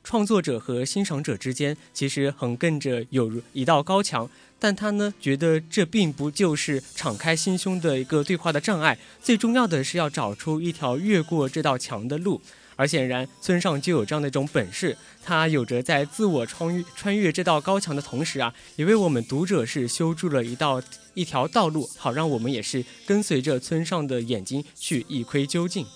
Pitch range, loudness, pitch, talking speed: 130-175 Hz, -25 LUFS, 150 Hz, 290 characters per minute